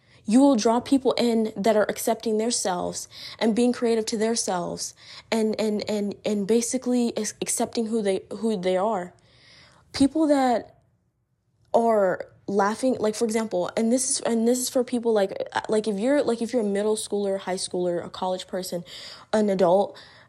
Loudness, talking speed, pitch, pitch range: -24 LUFS, 170 wpm, 220 Hz, 195-235 Hz